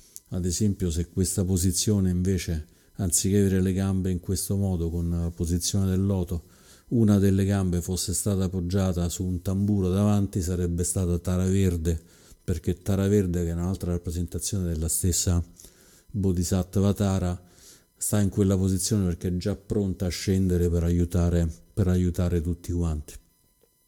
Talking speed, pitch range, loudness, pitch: 150 wpm, 85-95 Hz, -26 LUFS, 90 Hz